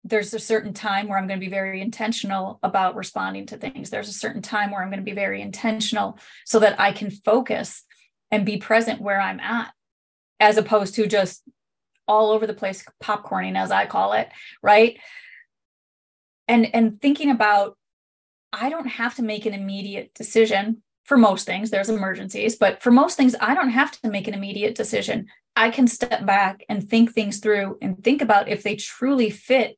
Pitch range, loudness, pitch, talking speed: 200-230 Hz, -21 LUFS, 215 Hz, 190 wpm